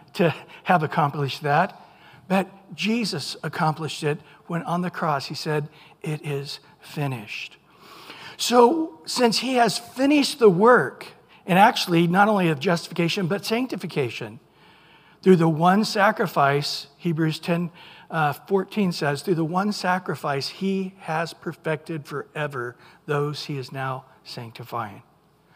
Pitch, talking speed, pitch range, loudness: 170 Hz, 125 wpm, 145-195 Hz, -23 LUFS